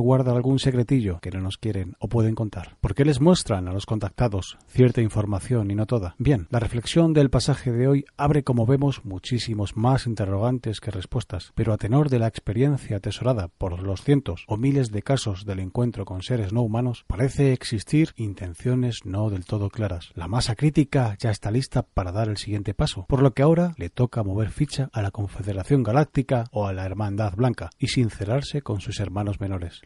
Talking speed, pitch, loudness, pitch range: 195 wpm, 115 Hz, -24 LUFS, 100-130 Hz